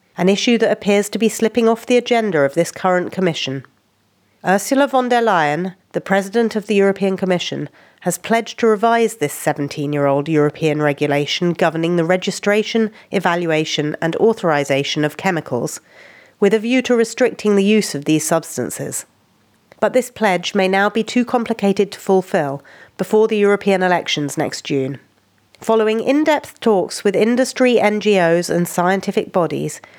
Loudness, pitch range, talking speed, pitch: -17 LUFS, 155-220 Hz, 150 wpm, 190 Hz